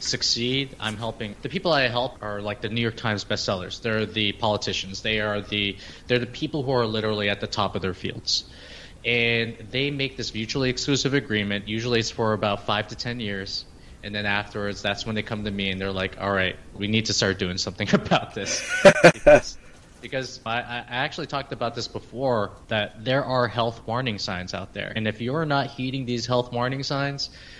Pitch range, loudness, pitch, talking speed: 100-125 Hz, -24 LUFS, 110 Hz, 205 wpm